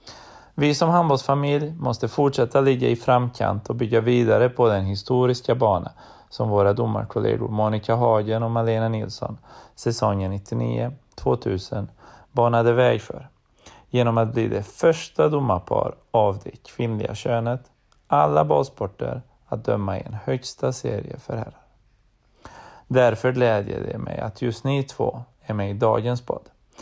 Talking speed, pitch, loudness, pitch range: 140 wpm, 115 Hz, -22 LUFS, 105-125 Hz